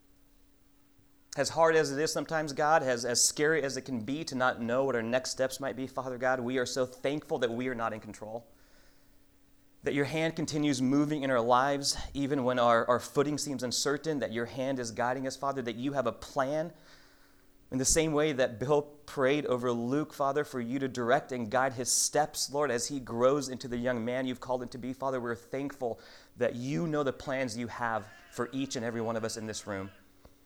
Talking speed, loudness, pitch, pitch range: 225 wpm, -31 LUFS, 130 Hz, 120-140 Hz